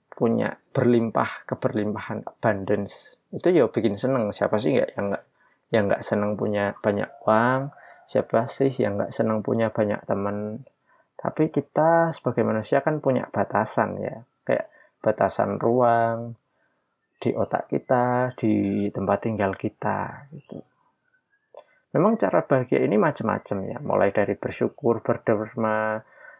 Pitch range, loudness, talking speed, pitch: 105-130 Hz, -24 LUFS, 125 wpm, 115 Hz